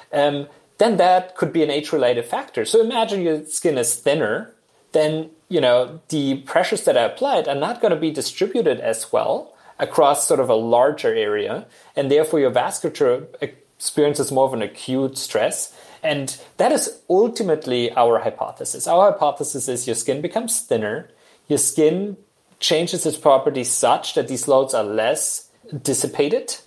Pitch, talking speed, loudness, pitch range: 155 Hz, 160 wpm, -20 LUFS, 135-220 Hz